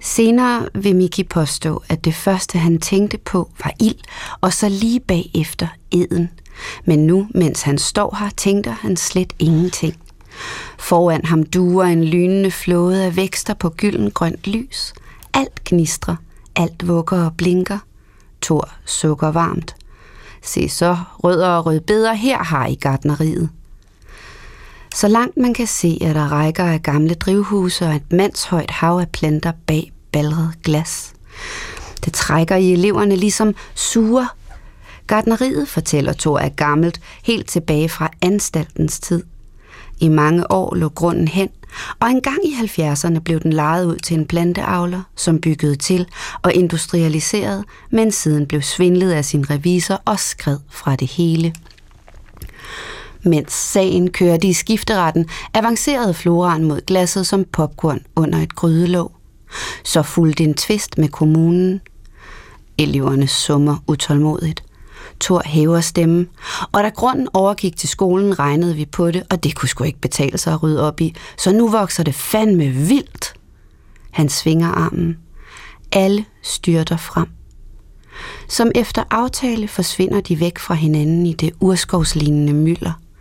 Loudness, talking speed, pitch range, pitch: -17 LUFS, 145 wpm, 155-195 Hz, 170 Hz